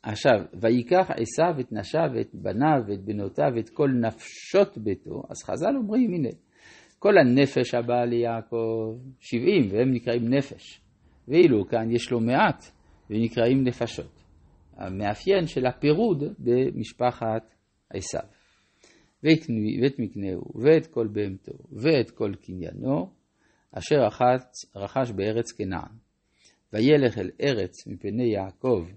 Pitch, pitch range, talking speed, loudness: 115 Hz, 100-130 Hz, 115 wpm, -25 LUFS